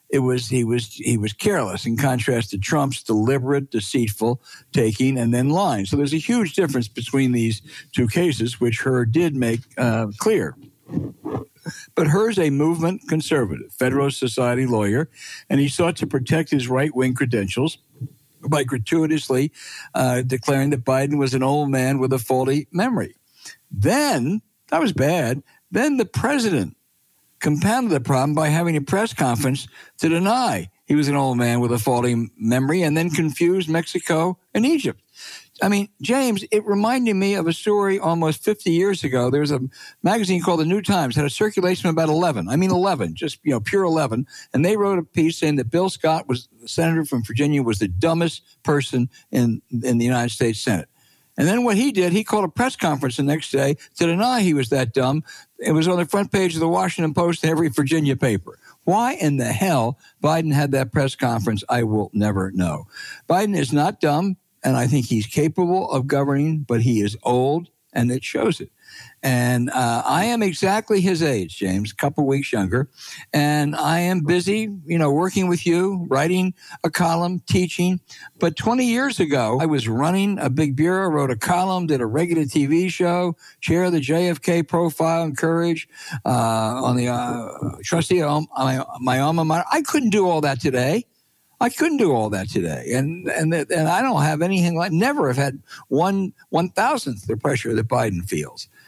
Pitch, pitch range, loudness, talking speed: 150 Hz, 130-175 Hz, -21 LUFS, 190 wpm